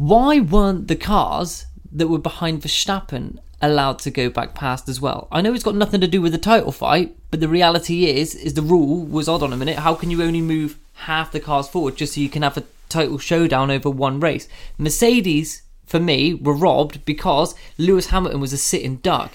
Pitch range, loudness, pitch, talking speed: 145-170 Hz, -19 LUFS, 160 Hz, 215 wpm